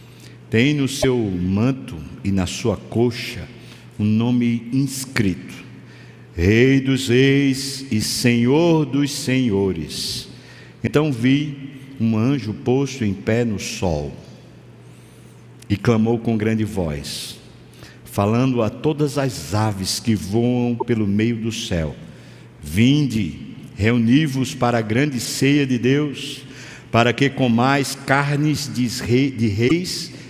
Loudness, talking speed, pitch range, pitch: -20 LUFS, 115 wpm, 105-135 Hz, 120 Hz